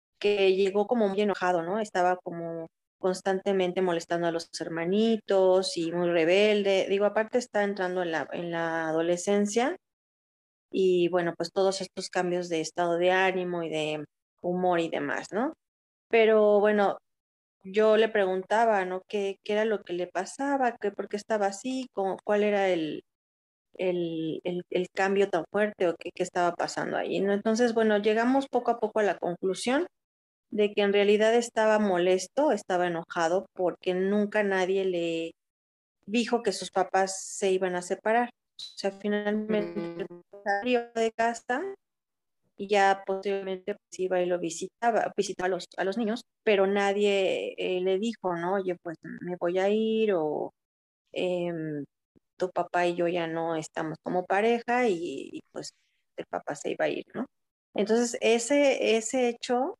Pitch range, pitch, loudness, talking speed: 175-215 Hz, 195 Hz, -27 LUFS, 160 wpm